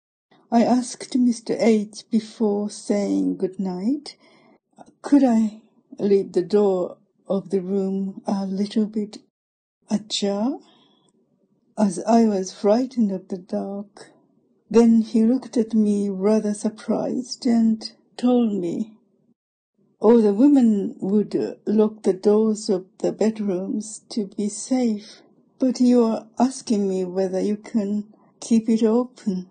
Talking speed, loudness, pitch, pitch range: 125 wpm, -22 LUFS, 215 Hz, 200-230 Hz